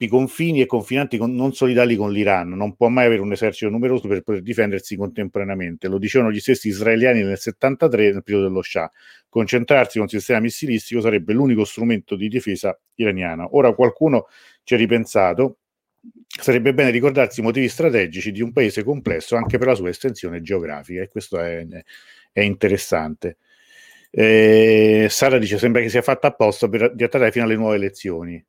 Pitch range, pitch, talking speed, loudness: 100-125 Hz, 115 Hz, 175 wpm, -18 LUFS